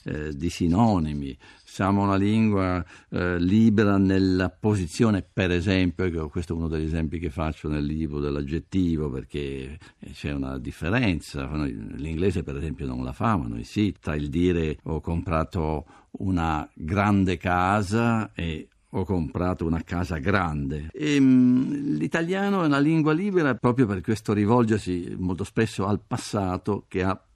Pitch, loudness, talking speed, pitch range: 90 Hz, -25 LUFS, 145 wpm, 80-105 Hz